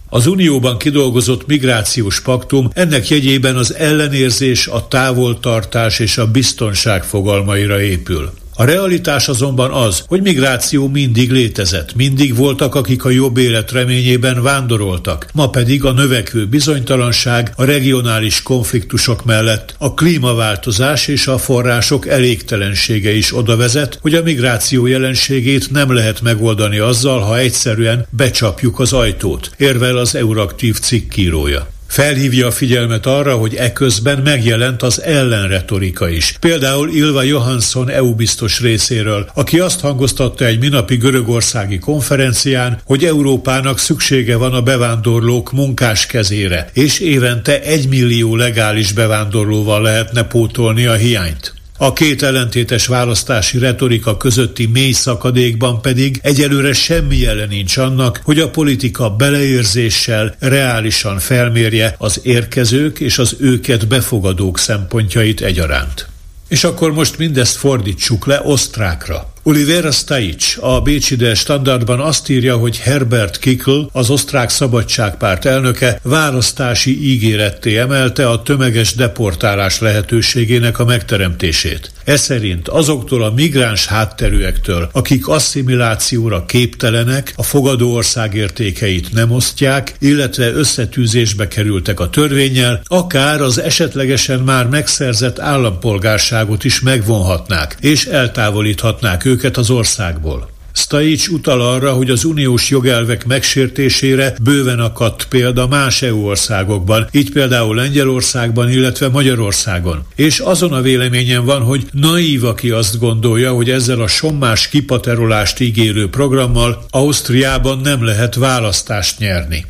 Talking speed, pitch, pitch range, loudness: 120 wpm, 125 Hz, 110-135 Hz, -12 LUFS